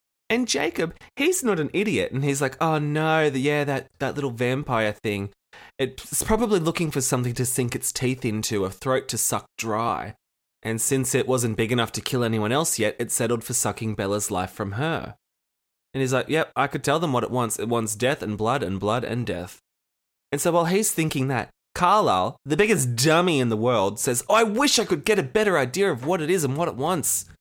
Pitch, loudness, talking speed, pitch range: 130 Hz, -23 LUFS, 225 wpm, 115-160 Hz